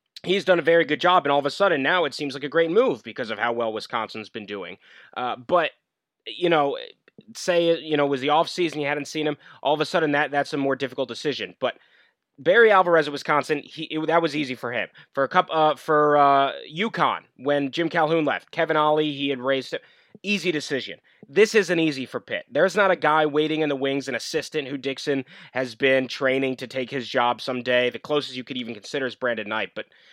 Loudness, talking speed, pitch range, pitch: -23 LUFS, 230 wpm, 130-165 Hz, 145 Hz